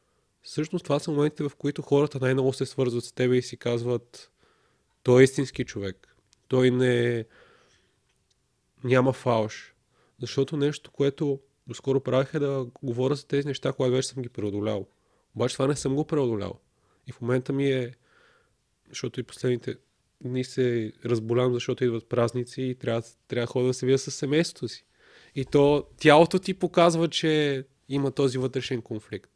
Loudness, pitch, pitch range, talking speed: -26 LUFS, 130 Hz, 120-140 Hz, 165 wpm